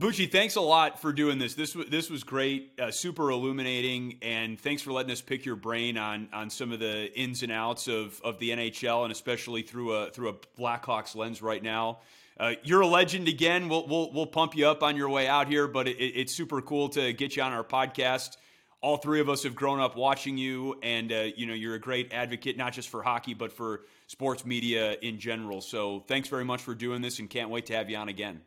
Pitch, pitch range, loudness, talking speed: 125 Hz, 115-140 Hz, -30 LUFS, 240 wpm